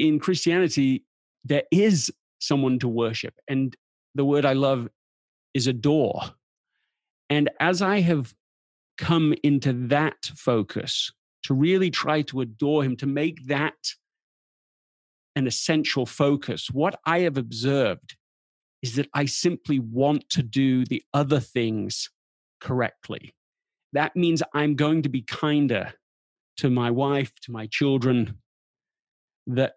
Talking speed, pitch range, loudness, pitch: 125 wpm, 125-150 Hz, -24 LUFS, 140 Hz